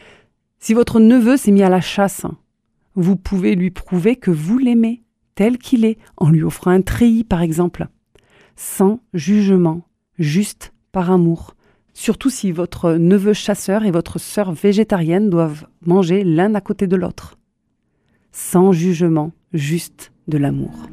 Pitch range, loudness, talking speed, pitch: 170-210 Hz, -16 LUFS, 145 wpm, 190 Hz